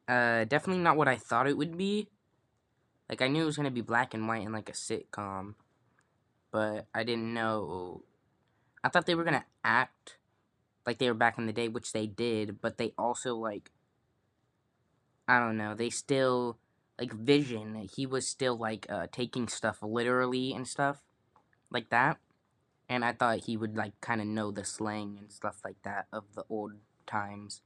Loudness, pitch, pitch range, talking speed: -32 LUFS, 115 Hz, 110-130 Hz, 190 wpm